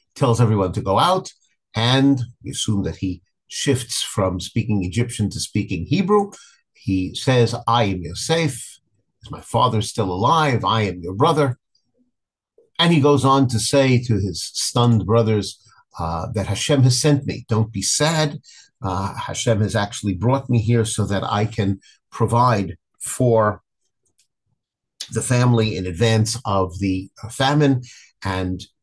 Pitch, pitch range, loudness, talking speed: 115 Hz, 100-130 Hz, -20 LUFS, 150 wpm